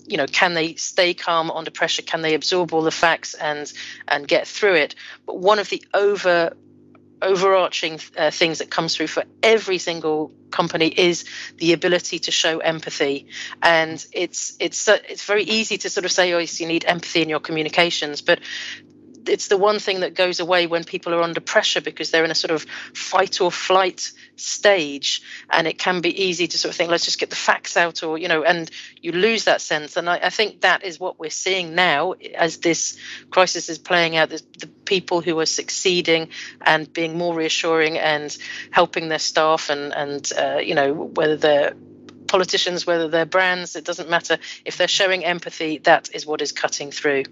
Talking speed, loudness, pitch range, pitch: 200 wpm, -20 LUFS, 160-185 Hz, 170 Hz